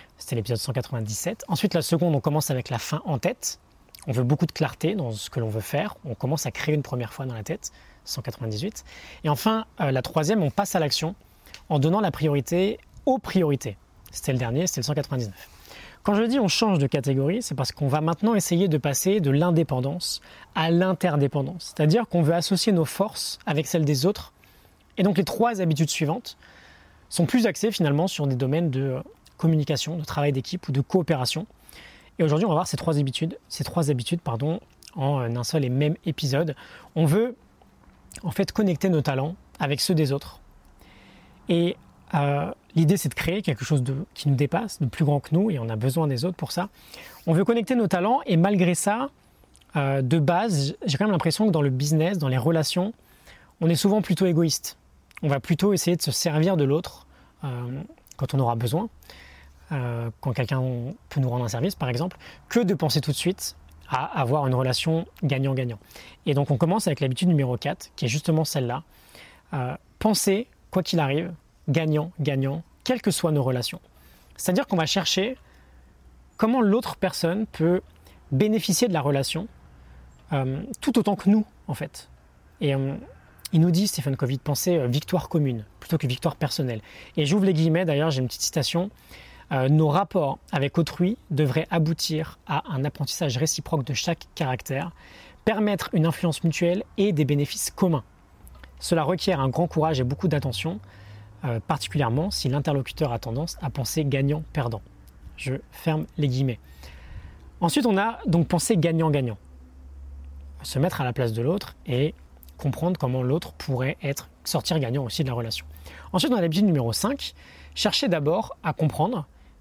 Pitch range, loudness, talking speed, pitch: 130-175 Hz, -25 LUFS, 185 wpm, 150 Hz